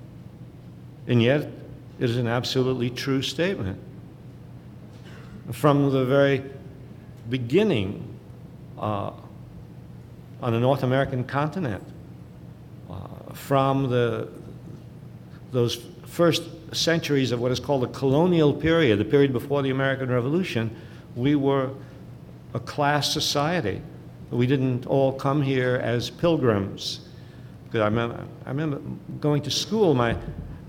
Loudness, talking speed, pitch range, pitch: -24 LUFS, 105 wpm, 120-145 Hz, 135 Hz